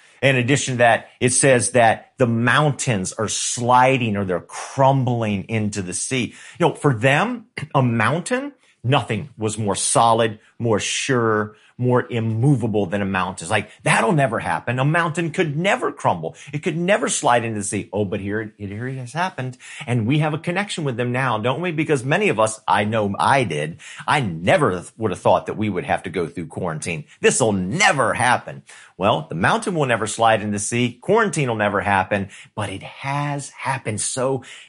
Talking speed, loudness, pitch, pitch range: 195 wpm, -20 LUFS, 125 Hz, 110-145 Hz